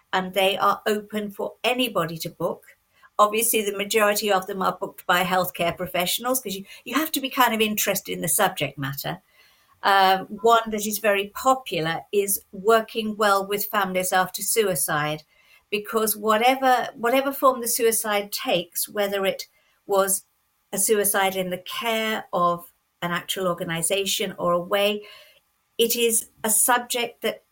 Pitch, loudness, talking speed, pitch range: 205 Hz, -23 LUFS, 155 wpm, 185-225 Hz